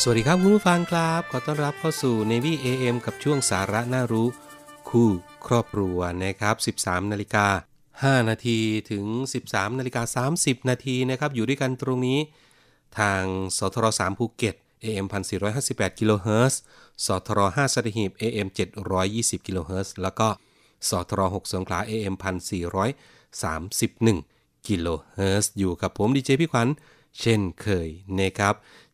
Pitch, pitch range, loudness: 110 Hz, 95-130 Hz, -25 LUFS